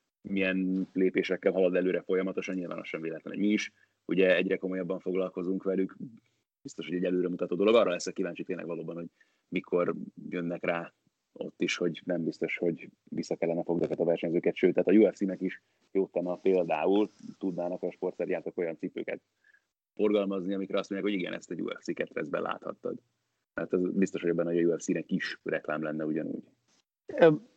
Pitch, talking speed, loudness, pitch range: 95 Hz, 170 wpm, -31 LUFS, 85-95 Hz